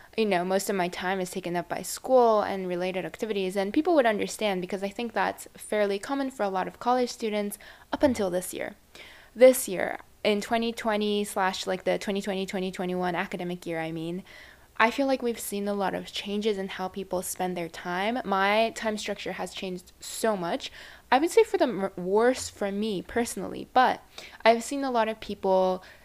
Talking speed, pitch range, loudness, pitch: 195 wpm, 185-225 Hz, -27 LUFS, 200 Hz